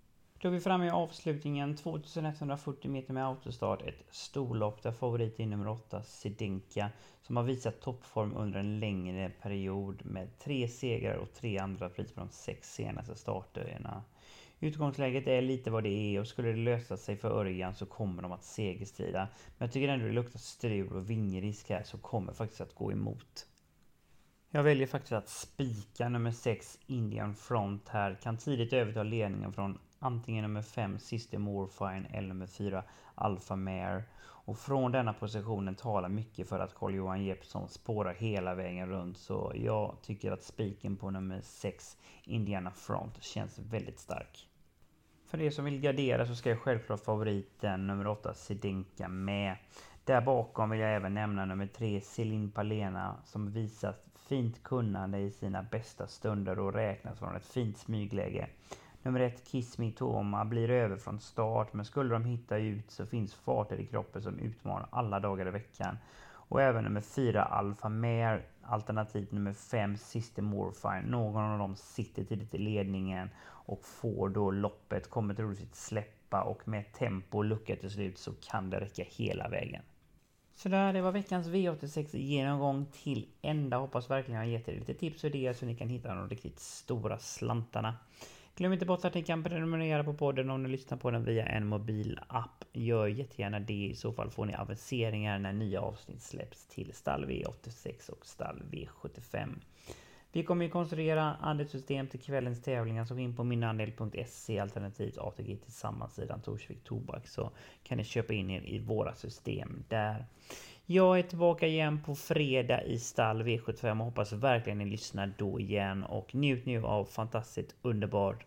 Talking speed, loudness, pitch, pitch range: 175 wpm, -36 LUFS, 110 Hz, 100-125 Hz